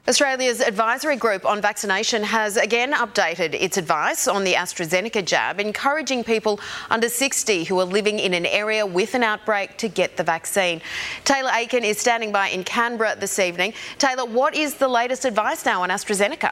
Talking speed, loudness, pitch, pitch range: 180 wpm, -21 LUFS, 215 Hz, 195-245 Hz